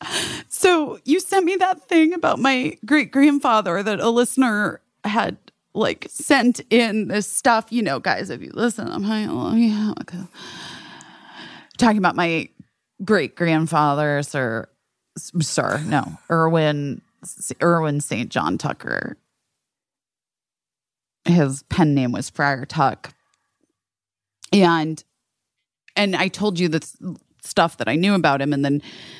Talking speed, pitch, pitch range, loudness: 130 wpm, 185 Hz, 150-240 Hz, -20 LUFS